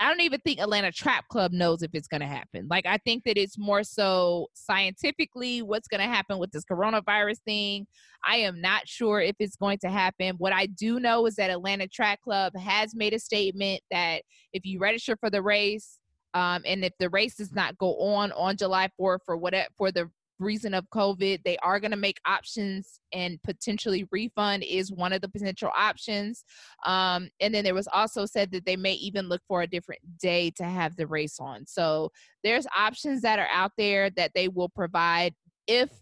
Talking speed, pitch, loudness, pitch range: 210 wpm, 195 Hz, -27 LUFS, 180-210 Hz